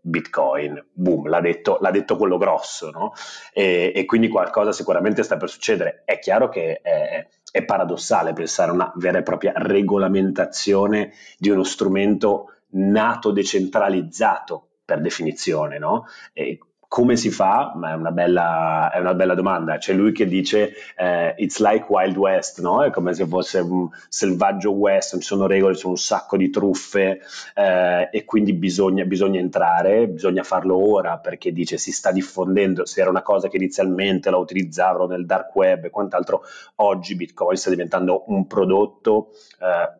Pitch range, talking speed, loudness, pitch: 90-105 Hz, 165 wpm, -20 LUFS, 95 Hz